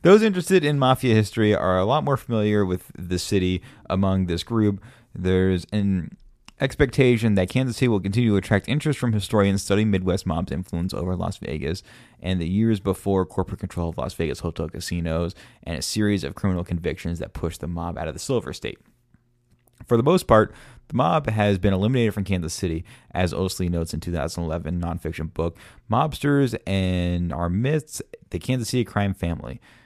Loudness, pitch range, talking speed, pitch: -23 LUFS, 90-115 Hz, 180 wpm, 95 Hz